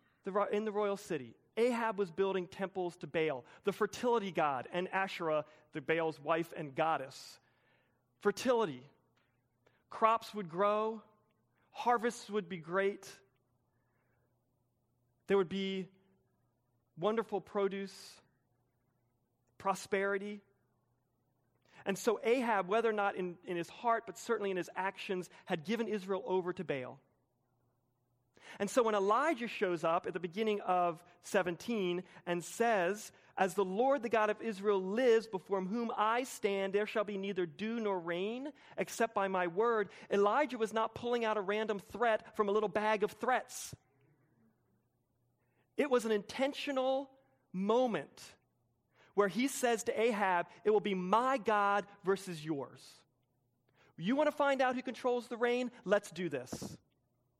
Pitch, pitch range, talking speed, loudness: 195 Hz, 160-220 Hz, 140 wpm, -35 LUFS